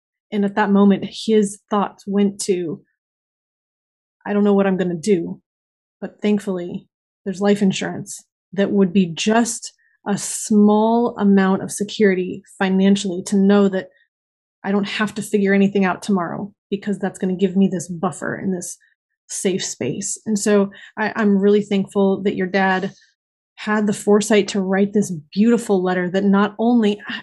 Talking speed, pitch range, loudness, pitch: 165 wpm, 195-210 Hz, -19 LUFS, 200 Hz